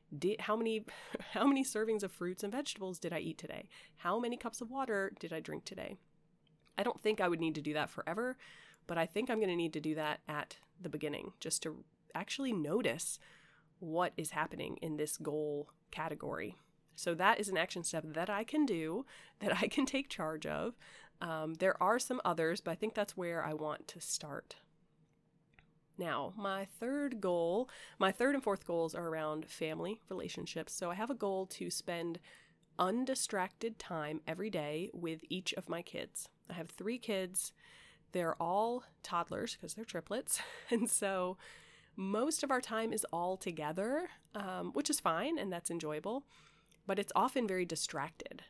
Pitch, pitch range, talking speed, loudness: 185 Hz, 160-220 Hz, 180 wpm, -38 LUFS